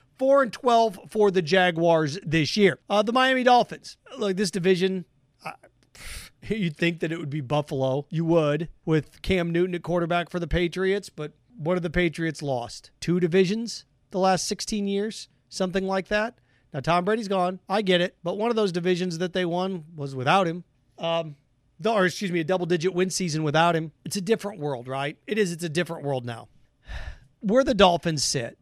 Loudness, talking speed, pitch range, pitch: -25 LUFS, 195 wpm, 155-195 Hz, 180 Hz